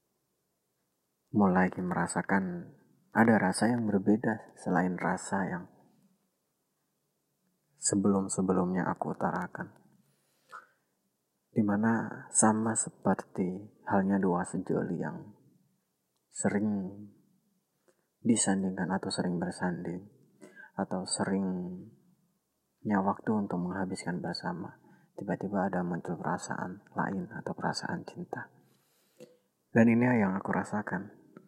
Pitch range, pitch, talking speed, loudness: 95-110 Hz, 100 Hz, 80 wpm, -31 LUFS